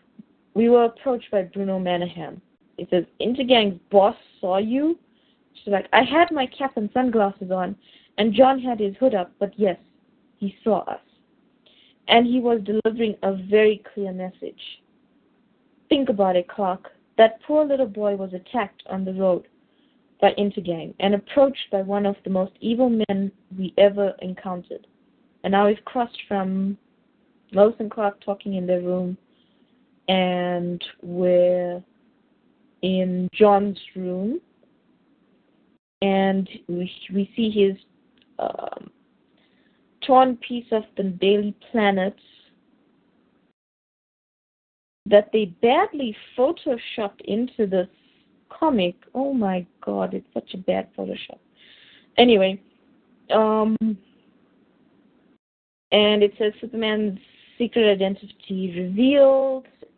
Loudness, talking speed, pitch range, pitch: -22 LUFS, 120 wpm, 195-250 Hz, 215 Hz